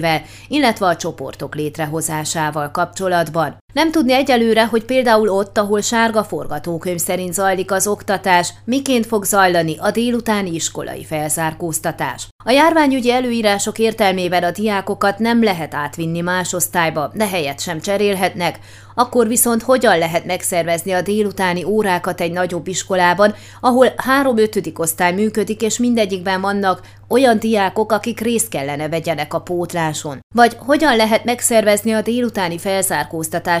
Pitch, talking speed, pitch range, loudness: 190 Hz, 130 wpm, 170-225 Hz, -17 LUFS